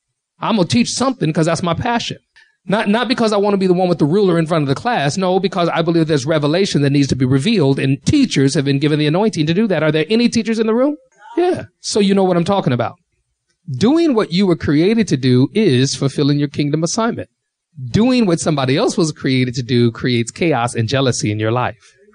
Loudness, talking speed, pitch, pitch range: -16 LUFS, 240 wpm, 165 Hz, 135-205 Hz